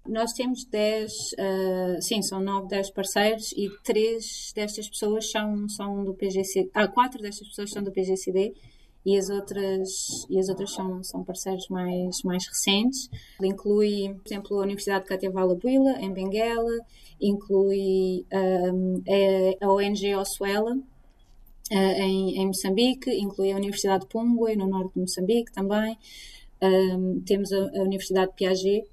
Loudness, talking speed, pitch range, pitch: -26 LUFS, 150 wpm, 190-210 Hz, 195 Hz